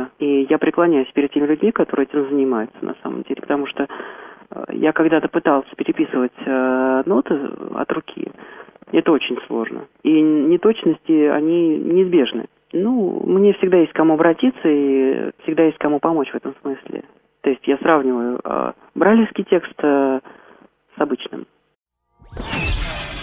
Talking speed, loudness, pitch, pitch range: 140 wpm, -18 LUFS, 155 Hz, 135-170 Hz